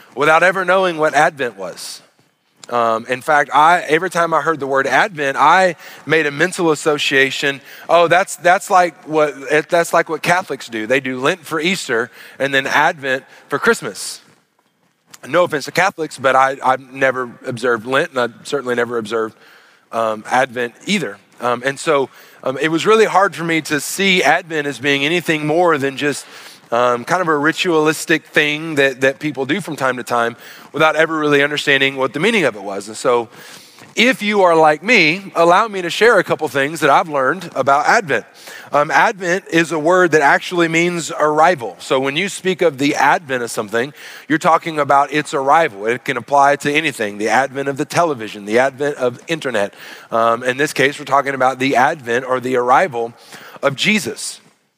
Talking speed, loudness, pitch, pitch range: 190 wpm, -16 LUFS, 150 Hz, 130-165 Hz